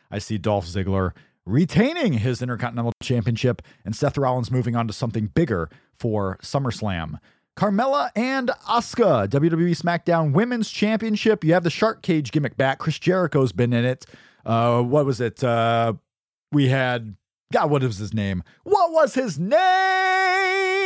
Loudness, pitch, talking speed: -22 LUFS, 135 Hz, 150 wpm